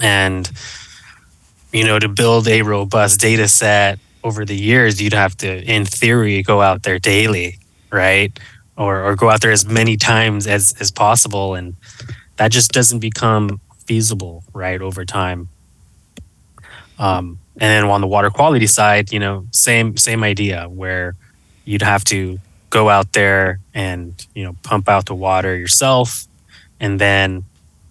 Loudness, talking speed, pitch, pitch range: -14 LUFS, 155 wpm, 100 Hz, 95-110 Hz